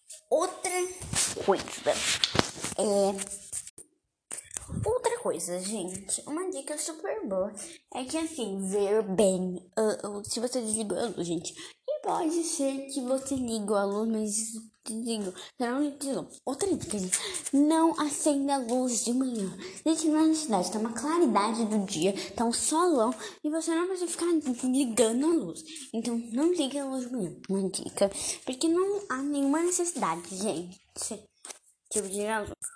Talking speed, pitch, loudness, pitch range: 145 wpm, 250 Hz, -29 LUFS, 205-310 Hz